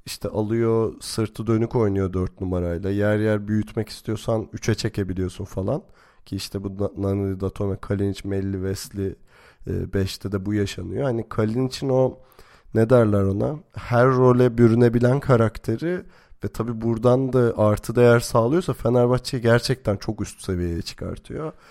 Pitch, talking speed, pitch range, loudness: 110 Hz, 140 wpm, 100-120 Hz, -22 LUFS